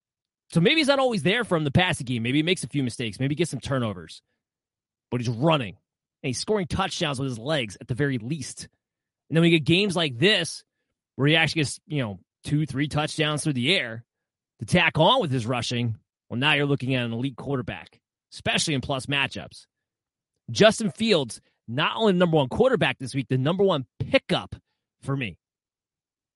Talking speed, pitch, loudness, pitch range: 200 wpm, 140 Hz, -24 LUFS, 125-165 Hz